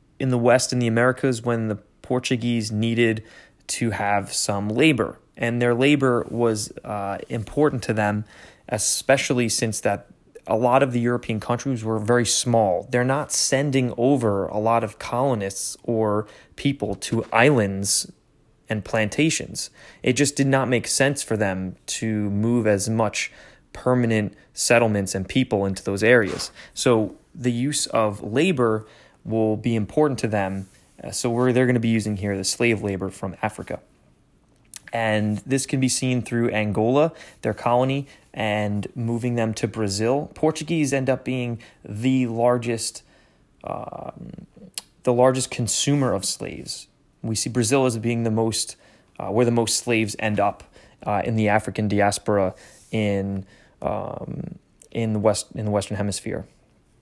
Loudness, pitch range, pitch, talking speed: -22 LUFS, 105-125 Hz, 115 Hz, 150 wpm